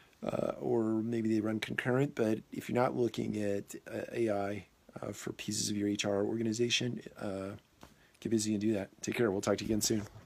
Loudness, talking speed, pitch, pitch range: -34 LUFS, 205 wpm, 110 Hz, 100-115 Hz